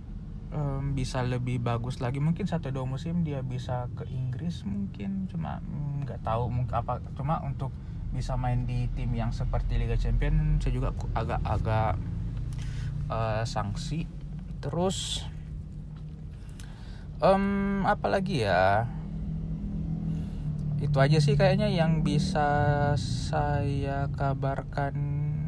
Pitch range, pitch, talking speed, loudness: 120-155 Hz, 135 Hz, 110 wpm, -29 LUFS